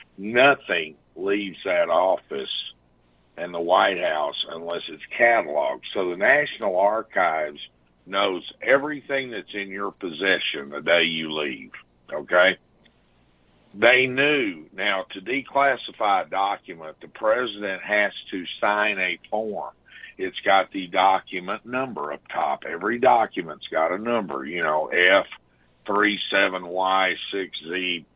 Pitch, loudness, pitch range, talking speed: 95 Hz, -23 LUFS, 75-110 Hz, 115 wpm